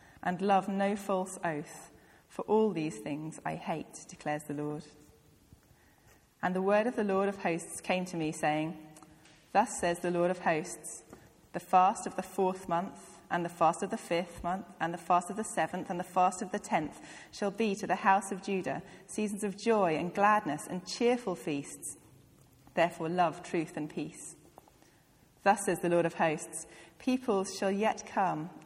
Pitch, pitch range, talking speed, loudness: 180 Hz, 165-200 Hz, 180 wpm, -32 LUFS